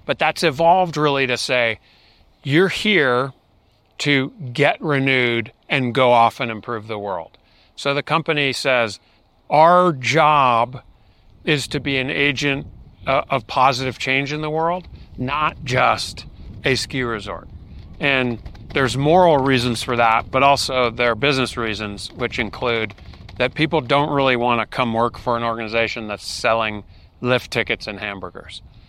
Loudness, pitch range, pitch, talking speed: -19 LUFS, 115-145 Hz, 125 Hz, 145 wpm